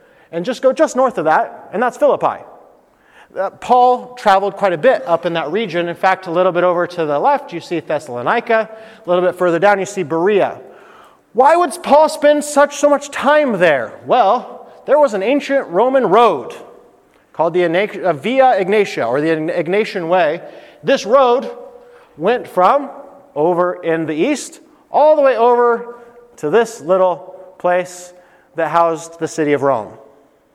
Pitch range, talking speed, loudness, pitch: 175-265 Hz, 165 wpm, -15 LUFS, 200 Hz